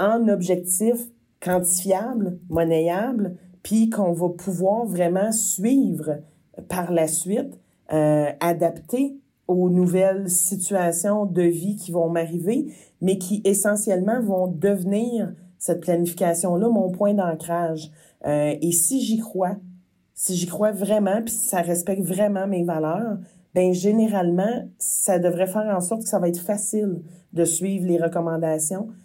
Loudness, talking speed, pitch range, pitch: -22 LUFS, 130 wpm, 175-205 Hz, 185 Hz